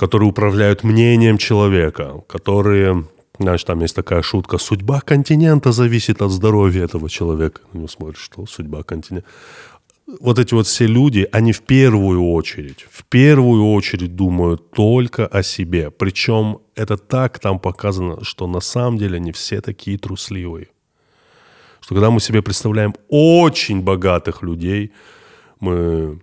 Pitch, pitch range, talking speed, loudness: 100 Hz, 90-110 Hz, 135 wpm, -16 LUFS